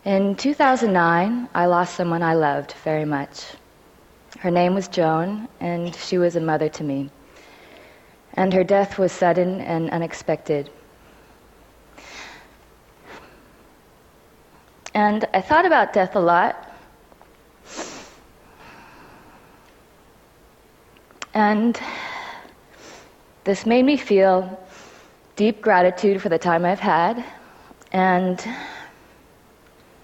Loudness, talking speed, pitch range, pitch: -20 LUFS, 95 wpm, 170-210 Hz, 185 Hz